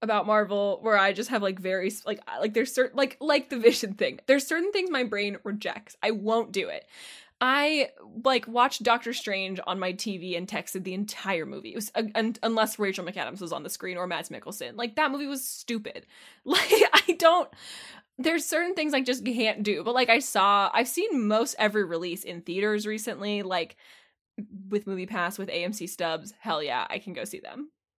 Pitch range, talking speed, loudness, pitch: 195-255 Hz, 205 wpm, -27 LUFS, 220 Hz